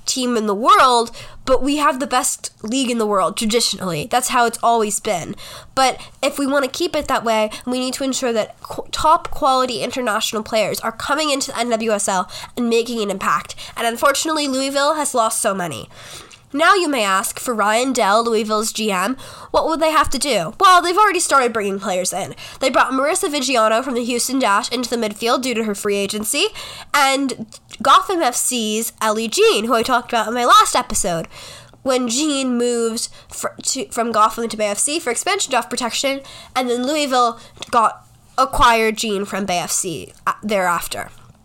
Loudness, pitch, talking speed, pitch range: -18 LUFS, 245 Hz, 190 wpm, 220-275 Hz